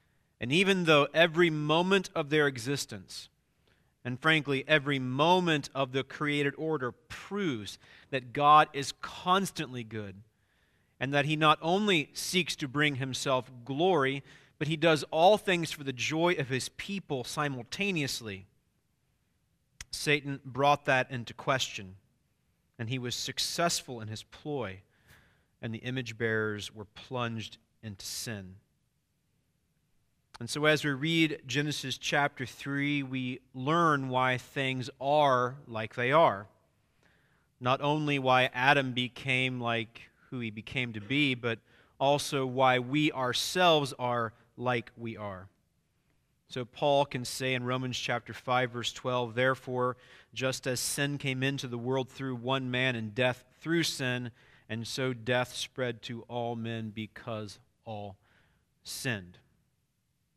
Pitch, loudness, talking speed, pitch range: 130 Hz, -30 LUFS, 135 wpm, 120-145 Hz